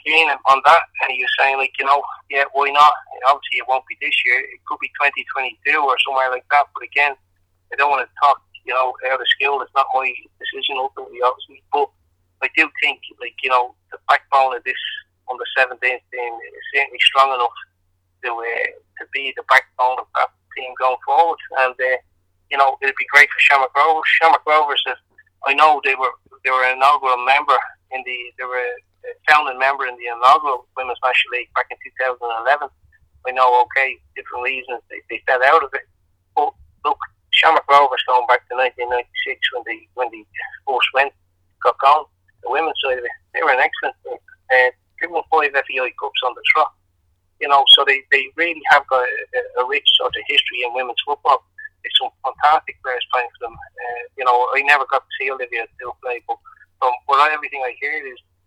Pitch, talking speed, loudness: 135 Hz, 205 wpm, -17 LUFS